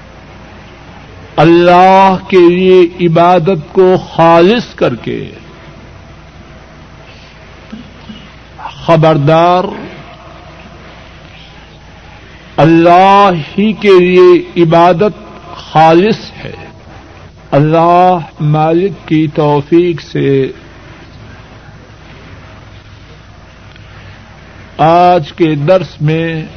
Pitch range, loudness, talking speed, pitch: 110-180 Hz, -8 LUFS, 55 wpm, 165 Hz